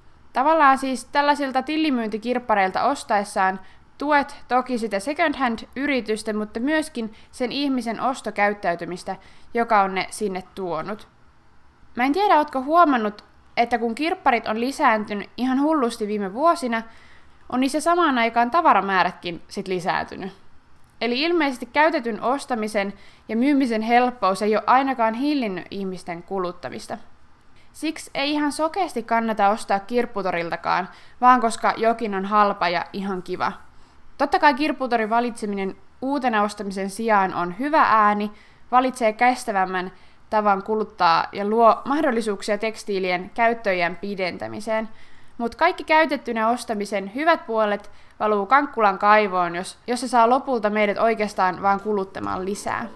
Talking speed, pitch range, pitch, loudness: 120 wpm, 200-260 Hz, 225 Hz, -22 LUFS